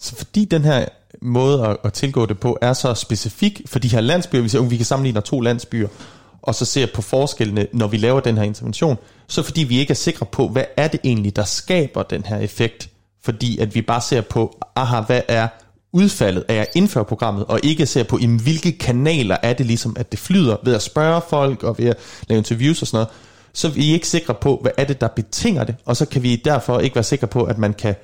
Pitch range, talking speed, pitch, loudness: 115-140 Hz, 245 wpm, 120 Hz, -19 LUFS